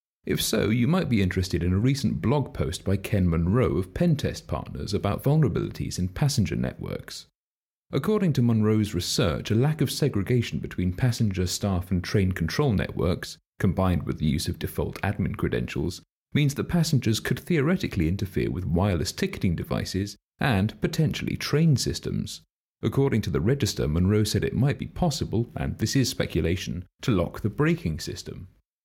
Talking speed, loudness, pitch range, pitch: 160 wpm, -26 LUFS, 90-135 Hz, 105 Hz